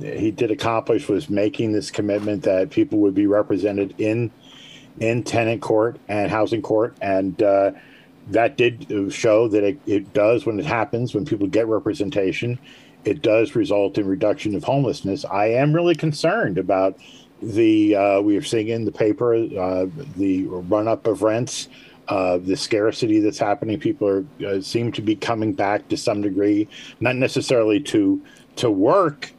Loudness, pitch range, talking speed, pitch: -21 LUFS, 100-120 Hz, 165 wpm, 110 Hz